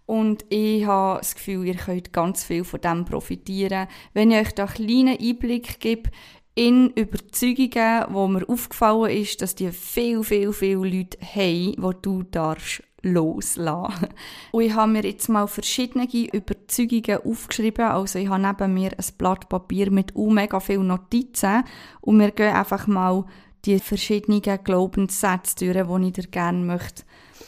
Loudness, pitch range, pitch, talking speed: -22 LUFS, 185-220 Hz, 200 Hz, 155 wpm